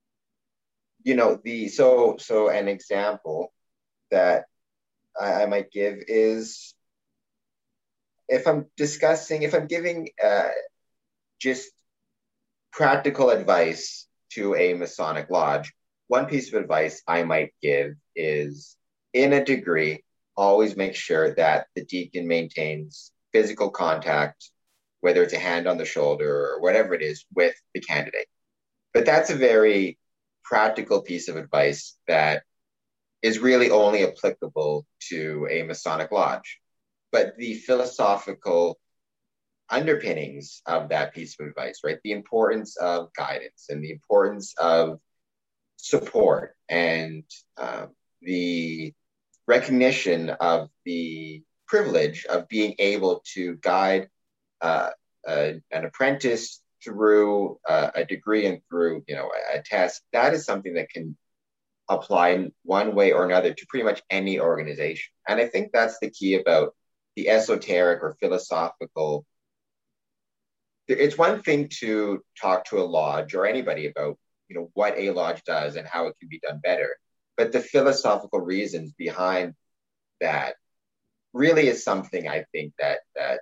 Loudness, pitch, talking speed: -24 LUFS, 105 Hz, 135 wpm